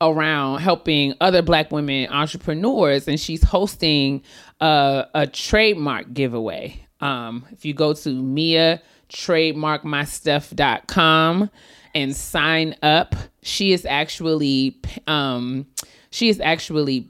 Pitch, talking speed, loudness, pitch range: 150 Hz, 100 wpm, -19 LUFS, 140-165 Hz